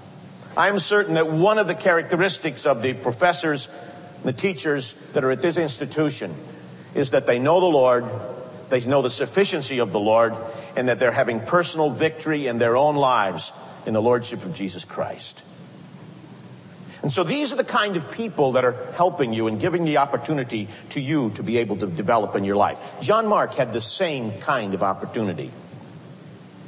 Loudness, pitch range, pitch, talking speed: -22 LUFS, 125-175 Hz, 145 Hz, 185 wpm